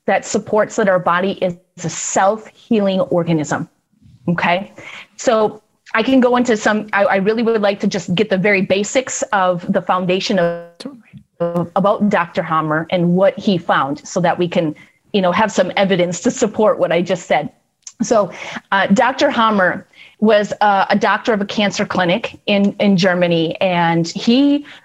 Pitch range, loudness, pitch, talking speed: 180-215 Hz, -16 LUFS, 195 Hz, 170 wpm